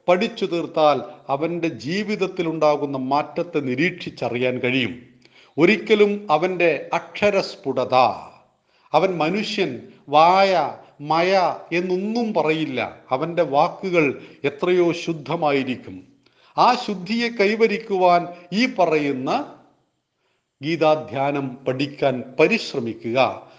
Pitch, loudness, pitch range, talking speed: 165 Hz, -21 LUFS, 140-185 Hz, 75 wpm